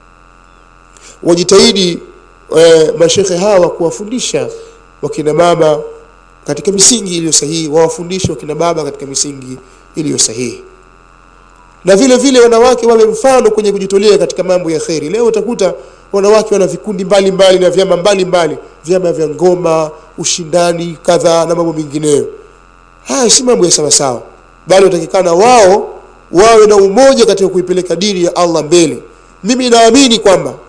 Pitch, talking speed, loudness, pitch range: 180 Hz, 130 wpm, -9 LUFS, 155-215 Hz